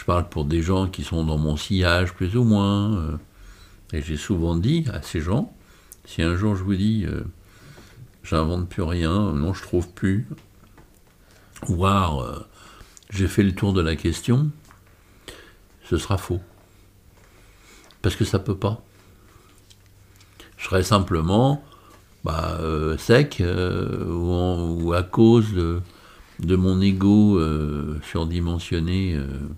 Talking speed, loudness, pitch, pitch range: 145 wpm, -22 LUFS, 95 Hz, 85-105 Hz